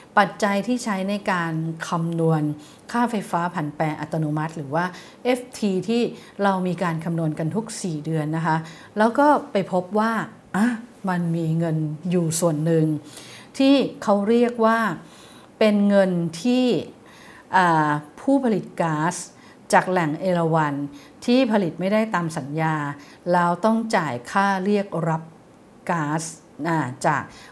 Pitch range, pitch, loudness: 160-210 Hz, 180 Hz, -22 LUFS